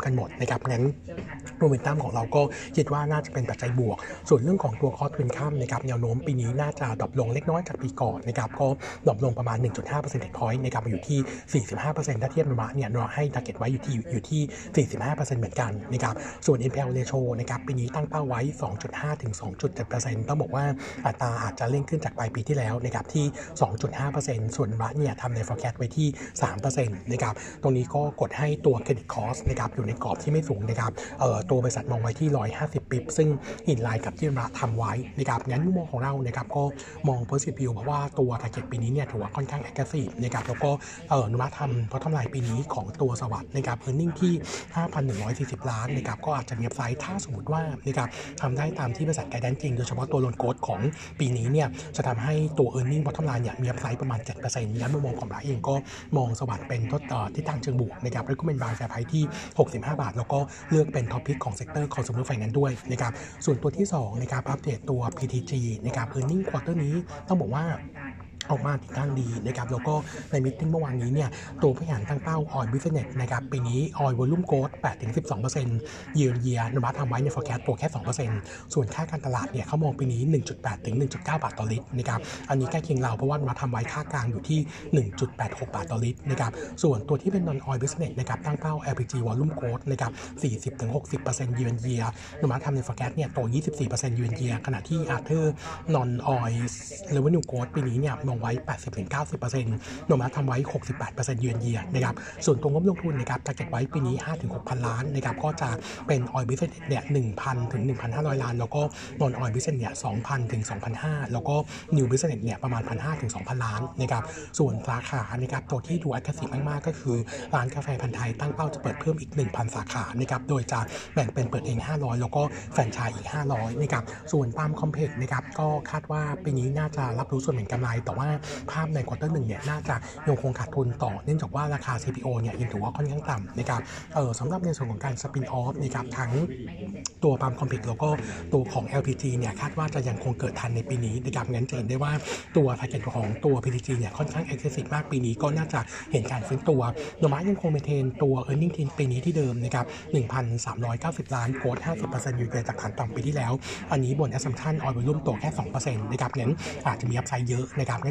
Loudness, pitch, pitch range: -28 LUFS, 130 Hz, 120-145 Hz